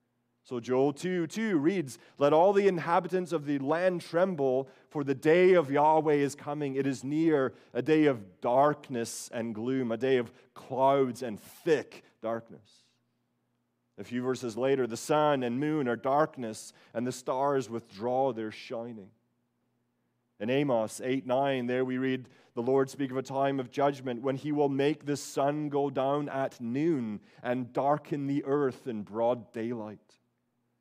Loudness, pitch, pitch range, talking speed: -30 LUFS, 135 Hz, 120-145 Hz, 160 wpm